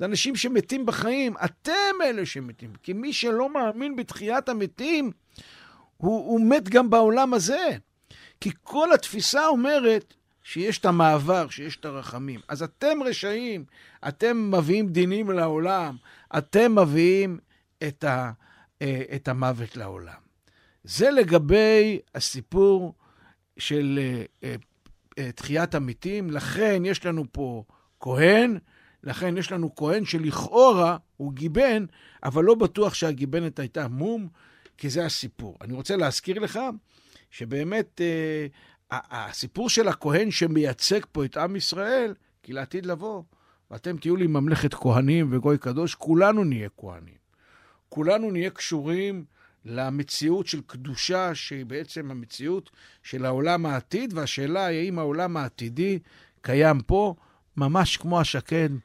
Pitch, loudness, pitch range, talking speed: 165 Hz, -24 LUFS, 140-205 Hz, 120 wpm